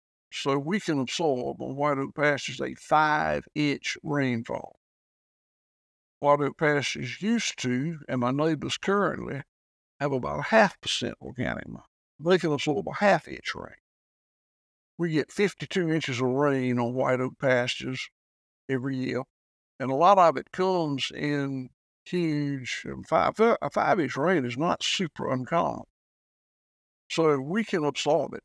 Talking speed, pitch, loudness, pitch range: 140 wpm, 140 Hz, -27 LUFS, 125-160 Hz